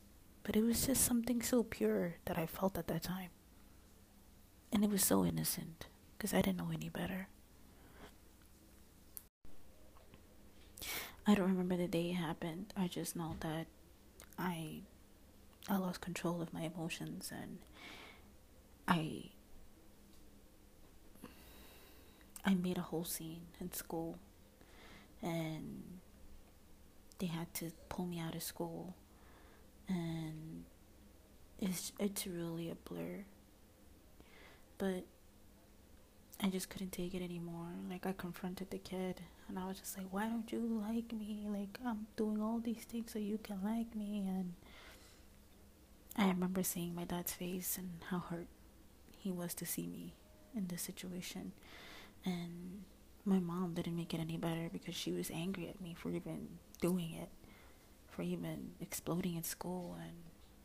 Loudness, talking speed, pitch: -41 LUFS, 140 wpm, 175 Hz